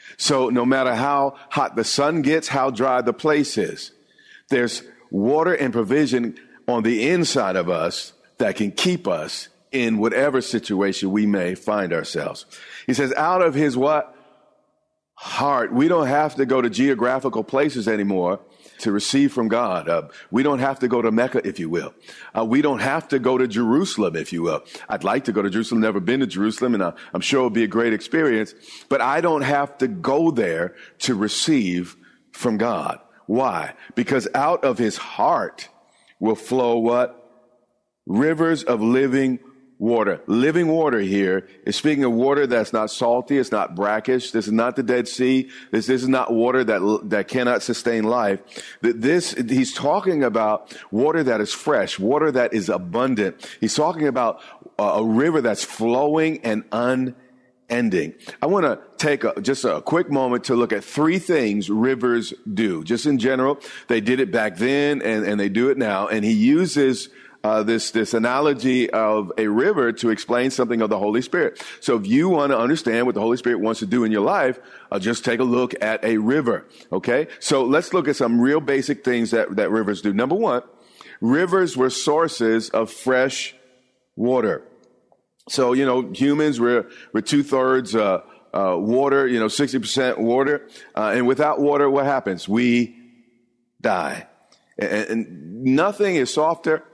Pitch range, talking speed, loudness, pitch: 115-135 Hz, 180 wpm, -21 LUFS, 125 Hz